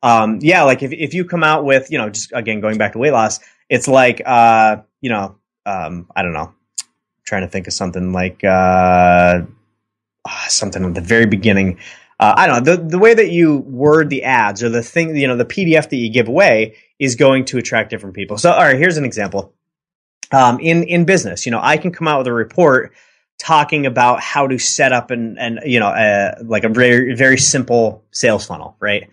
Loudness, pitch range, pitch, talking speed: -14 LUFS, 105-145 Hz, 120 Hz, 220 wpm